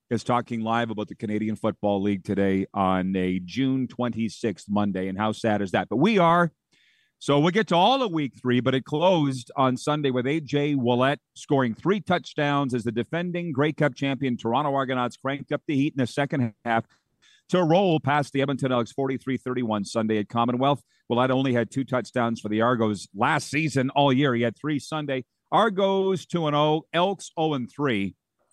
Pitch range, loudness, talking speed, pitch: 115-150 Hz, -25 LUFS, 190 wpm, 130 Hz